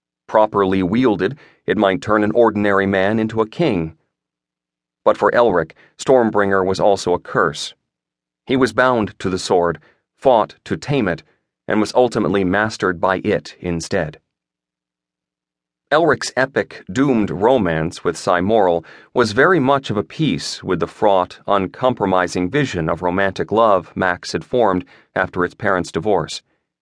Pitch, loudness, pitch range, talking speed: 95 Hz, -18 LUFS, 80-105 Hz, 140 wpm